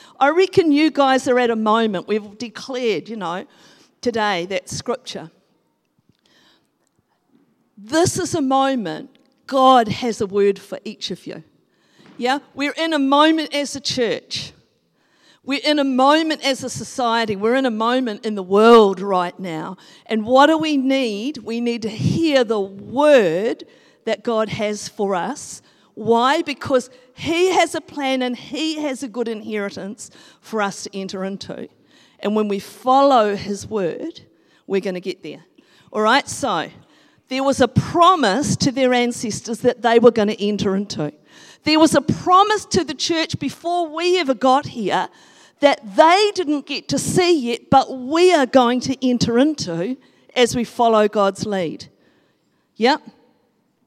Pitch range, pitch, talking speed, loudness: 210-285 Hz, 250 Hz, 160 wpm, -18 LUFS